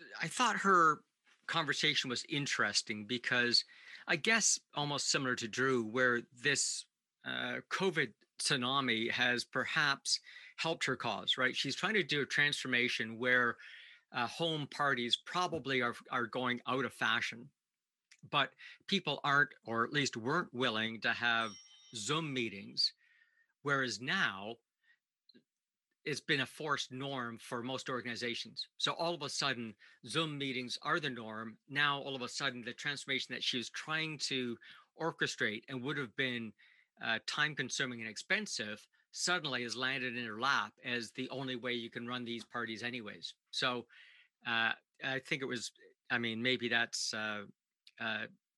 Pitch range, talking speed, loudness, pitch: 120-145 Hz, 150 wpm, -35 LUFS, 130 Hz